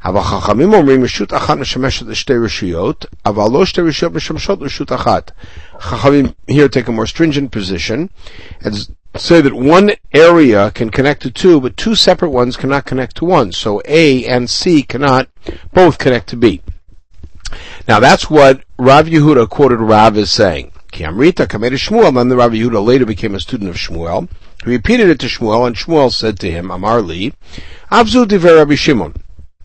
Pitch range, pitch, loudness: 105-155 Hz, 125 Hz, -11 LUFS